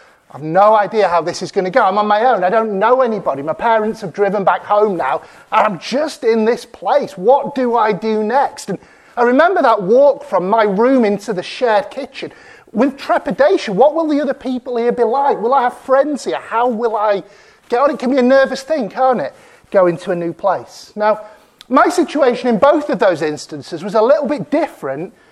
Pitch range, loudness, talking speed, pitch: 205-275 Hz, -15 LUFS, 220 wpm, 235 Hz